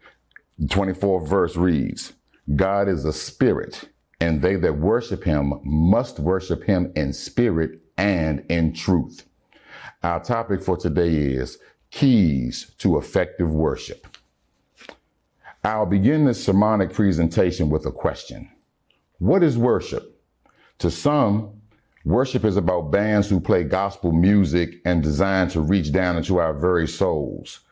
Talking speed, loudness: 130 wpm, -21 LUFS